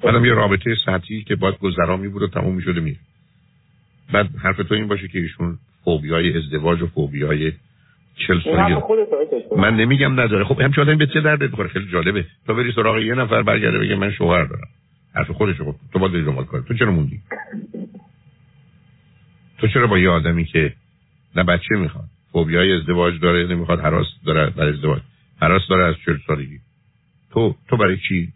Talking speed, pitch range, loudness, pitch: 185 wpm, 85-125 Hz, -18 LUFS, 100 Hz